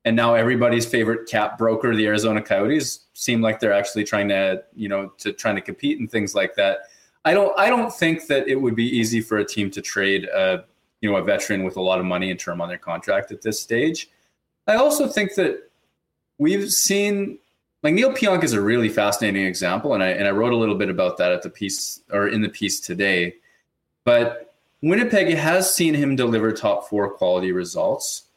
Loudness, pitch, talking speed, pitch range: -21 LUFS, 115 Hz, 210 wpm, 100-160 Hz